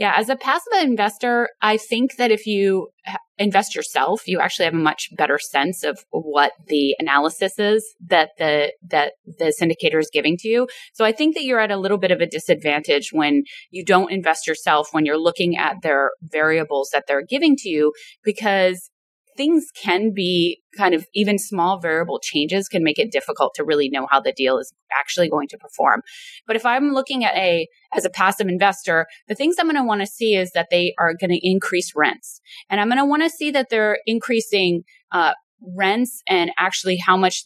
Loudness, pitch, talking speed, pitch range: -19 LUFS, 185 Hz, 205 wpm, 160-225 Hz